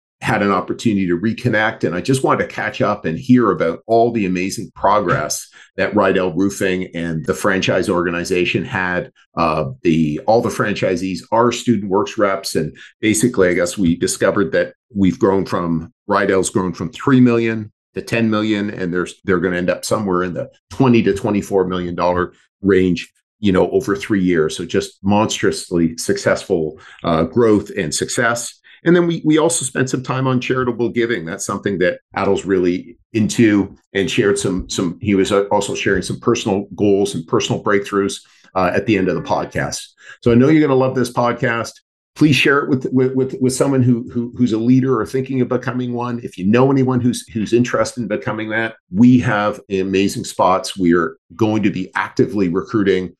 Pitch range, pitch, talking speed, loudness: 95-125 Hz, 105 Hz, 190 wpm, -17 LUFS